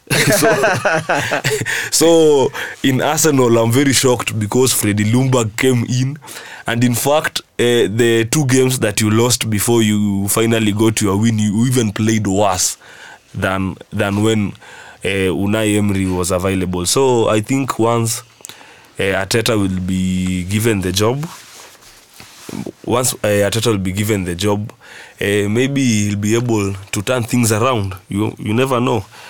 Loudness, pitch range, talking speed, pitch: -15 LUFS, 100-125 Hz, 145 wpm, 110 Hz